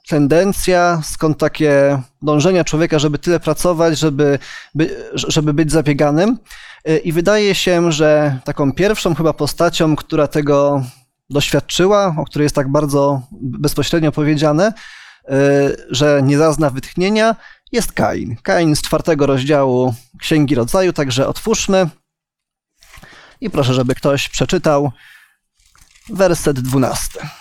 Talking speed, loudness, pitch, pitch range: 115 wpm, -15 LUFS, 150 Hz, 145-170 Hz